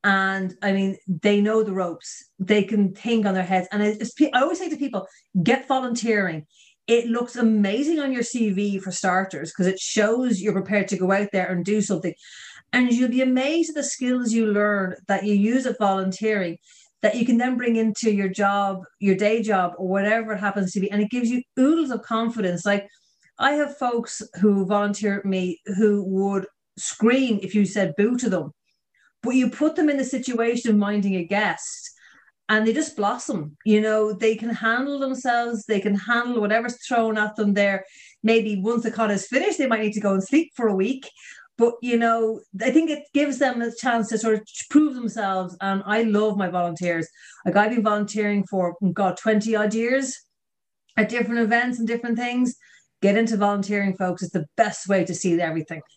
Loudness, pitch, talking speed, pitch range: -22 LUFS, 215 Hz, 200 wpm, 195-235 Hz